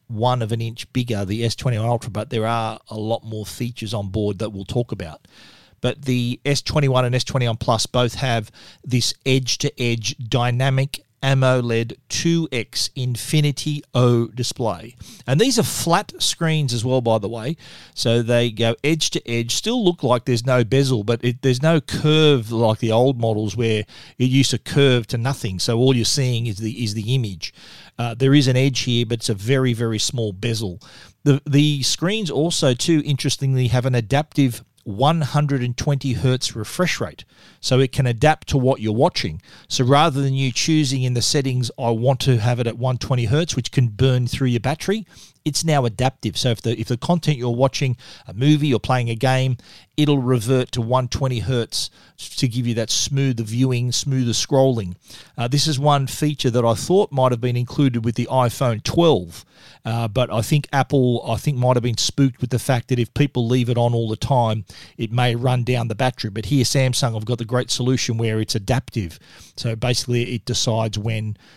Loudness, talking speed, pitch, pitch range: -20 LUFS, 190 wpm, 125 Hz, 115-135 Hz